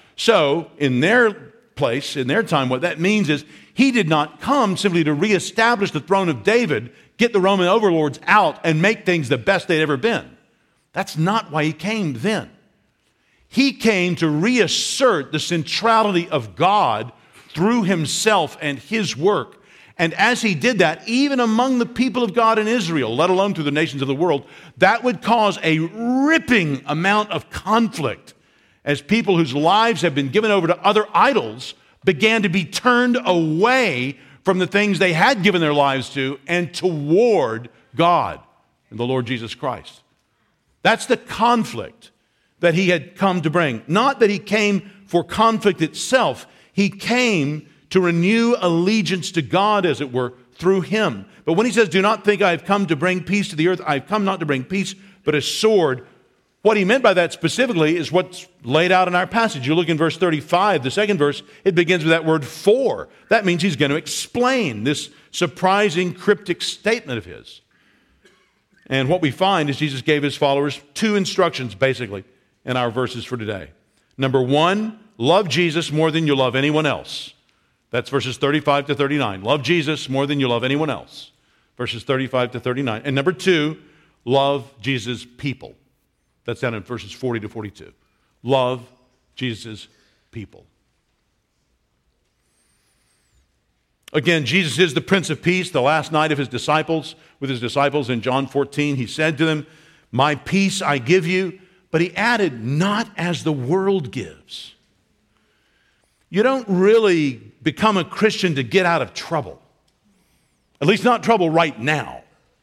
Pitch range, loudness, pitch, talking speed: 145-200 Hz, -19 LUFS, 170 Hz, 170 wpm